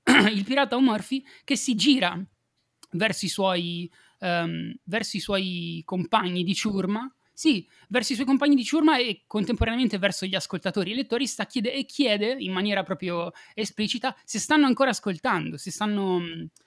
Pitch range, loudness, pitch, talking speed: 185-260 Hz, -25 LUFS, 215 Hz, 150 wpm